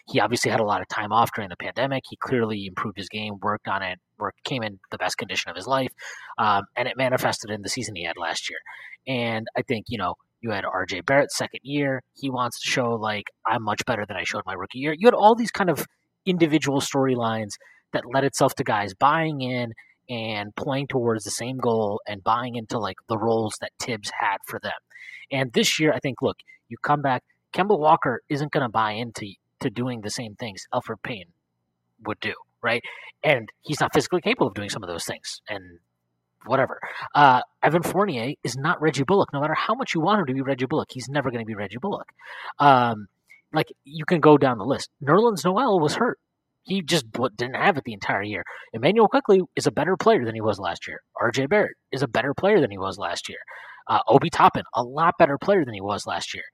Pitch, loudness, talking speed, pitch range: 130 Hz, -24 LUFS, 225 wpm, 110-150 Hz